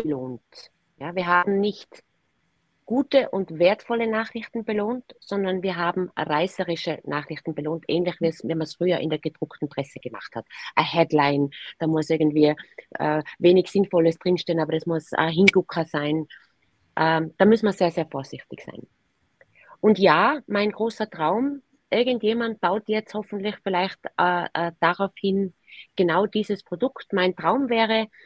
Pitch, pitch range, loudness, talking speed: 180 Hz, 160-210 Hz, -23 LUFS, 145 wpm